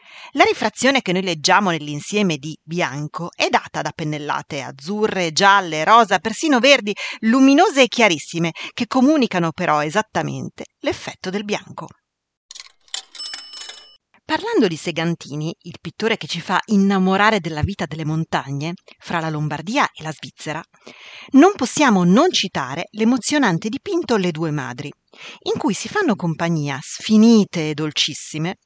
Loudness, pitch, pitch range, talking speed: -18 LUFS, 185 Hz, 160-230 Hz, 130 wpm